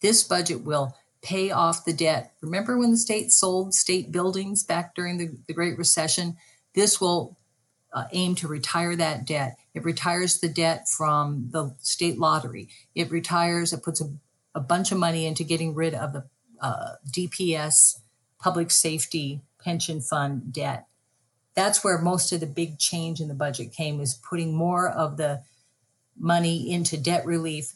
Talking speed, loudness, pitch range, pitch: 165 wpm, -24 LUFS, 145-175 Hz, 165 Hz